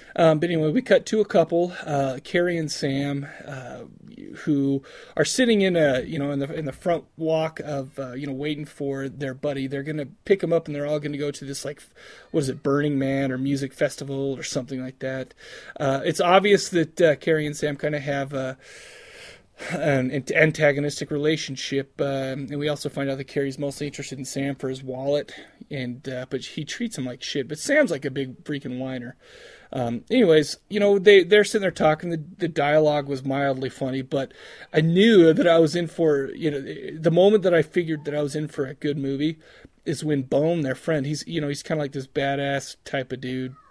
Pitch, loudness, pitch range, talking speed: 145 Hz, -23 LUFS, 135-160 Hz, 220 wpm